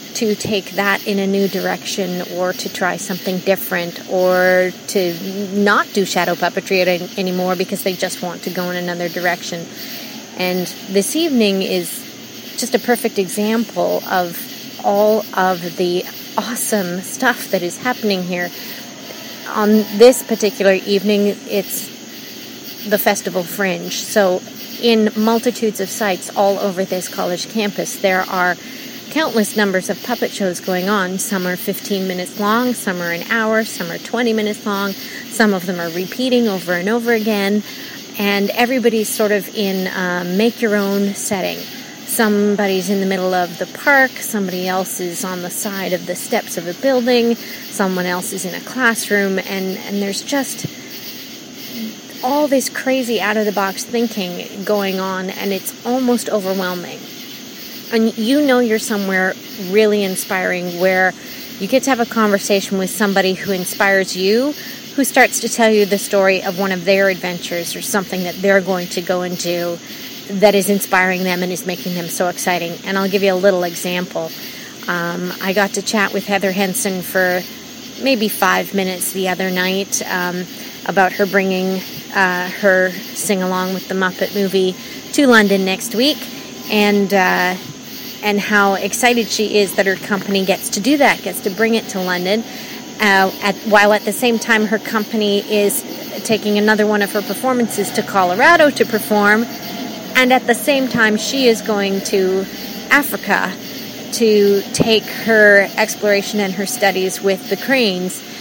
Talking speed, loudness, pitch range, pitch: 160 wpm, -17 LUFS, 190-230 Hz, 205 Hz